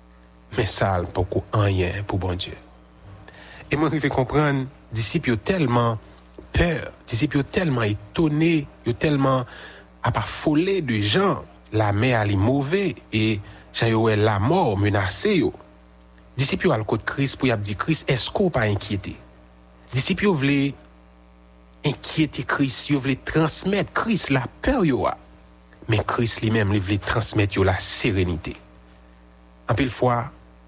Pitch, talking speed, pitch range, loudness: 110 Hz, 160 wpm, 90-140 Hz, -22 LUFS